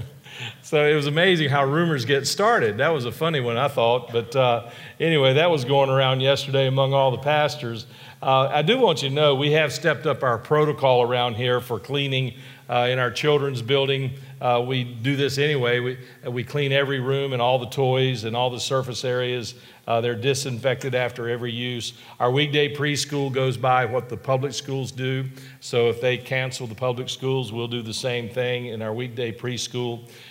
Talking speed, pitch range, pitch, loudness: 200 wpm, 120-140 Hz, 130 Hz, -22 LUFS